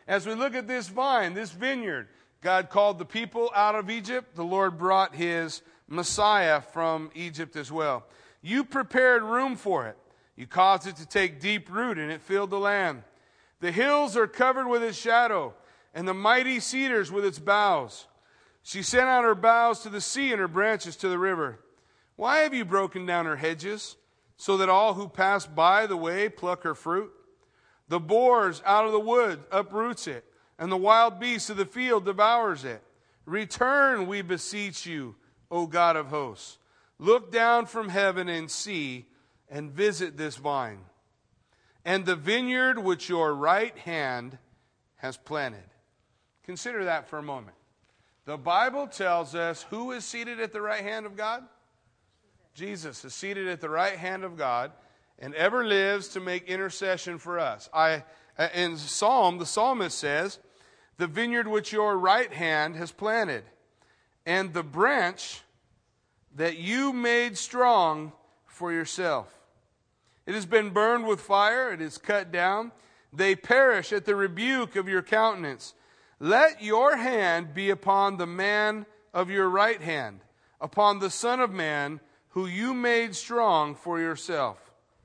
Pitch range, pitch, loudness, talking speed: 165-225 Hz, 195 Hz, -26 LUFS, 160 wpm